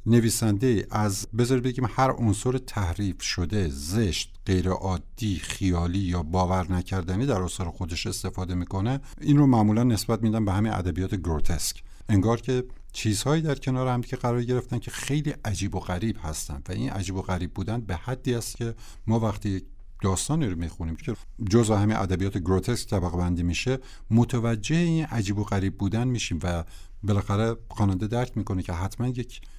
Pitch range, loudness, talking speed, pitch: 95-120 Hz, -27 LUFS, 165 wpm, 105 Hz